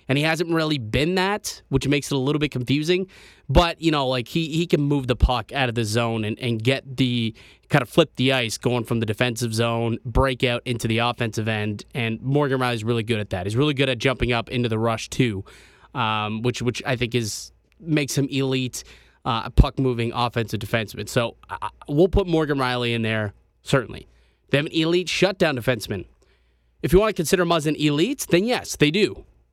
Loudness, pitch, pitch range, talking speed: -23 LUFS, 125 Hz, 115-145 Hz, 210 wpm